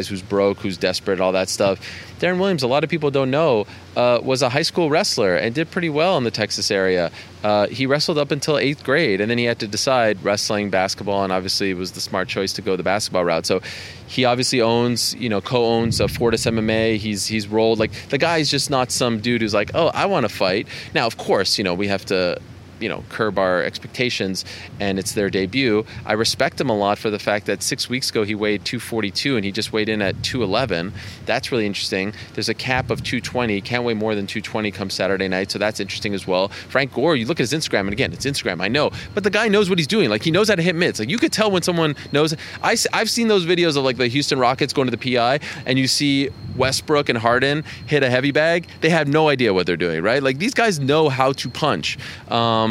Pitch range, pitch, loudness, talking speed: 100-140 Hz, 115 Hz, -20 LUFS, 255 wpm